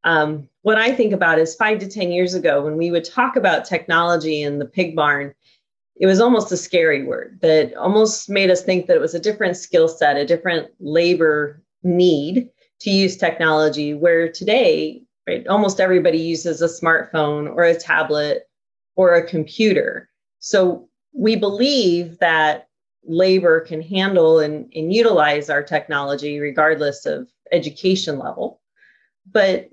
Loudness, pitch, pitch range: -18 LUFS, 170 Hz, 155-195 Hz